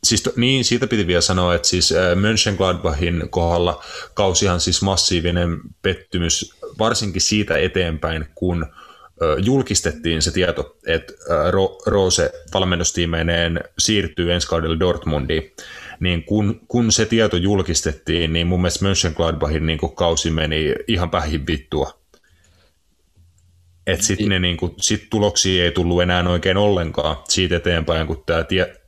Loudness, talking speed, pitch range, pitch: -19 LUFS, 125 wpm, 85-100 Hz, 90 Hz